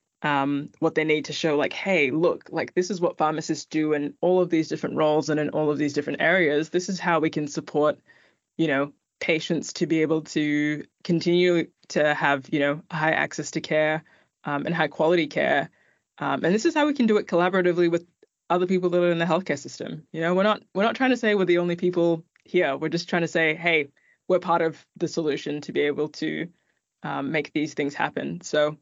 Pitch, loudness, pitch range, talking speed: 160 Hz, -24 LUFS, 150-175 Hz, 225 wpm